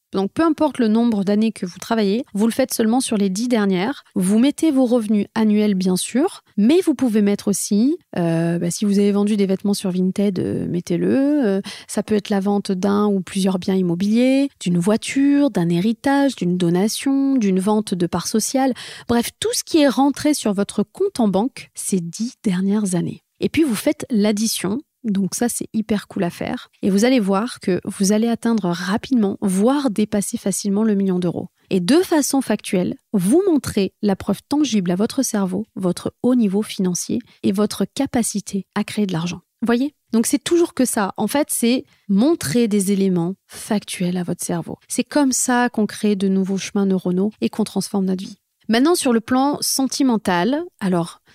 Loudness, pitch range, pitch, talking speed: -19 LUFS, 195-250 Hz, 210 Hz, 195 wpm